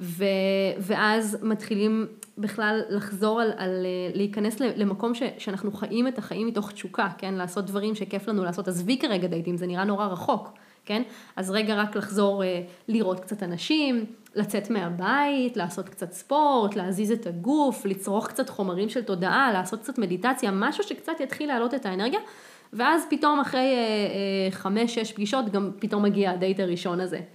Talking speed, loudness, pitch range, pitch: 160 wpm, -26 LUFS, 190-235 Hz, 210 Hz